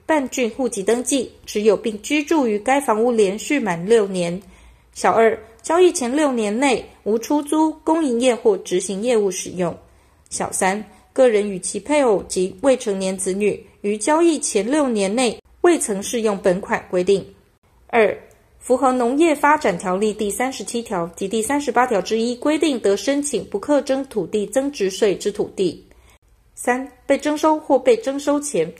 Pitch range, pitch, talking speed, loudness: 205-290 Hz, 240 Hz, 245 characters per minute, -19 LUFS